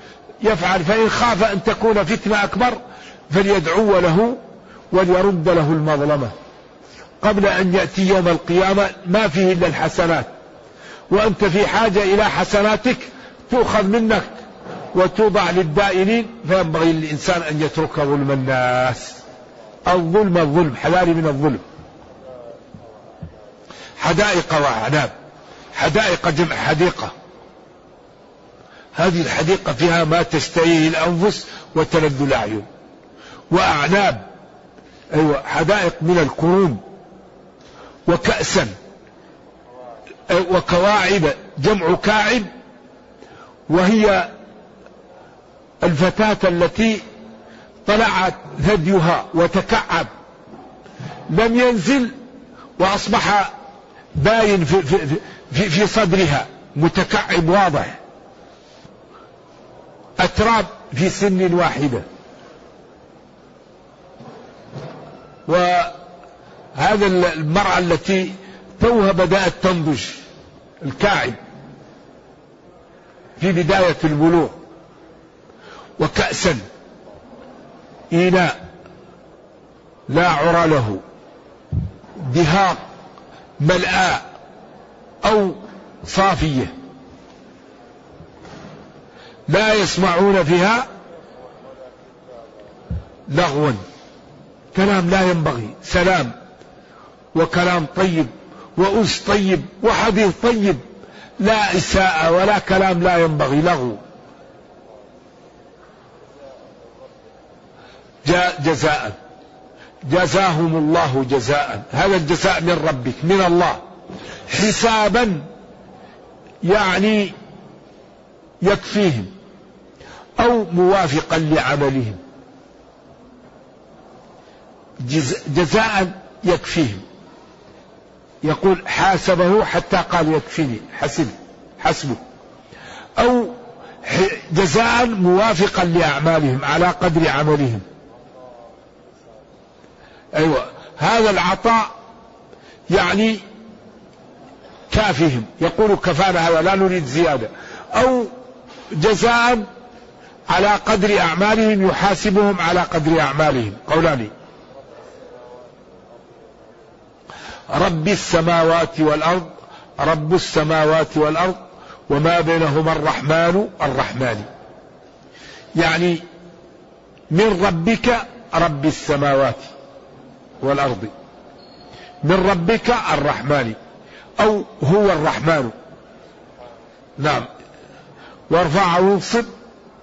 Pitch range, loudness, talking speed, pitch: 160-205 Hz, -17 LUFS, 70 wpm, 180 Hz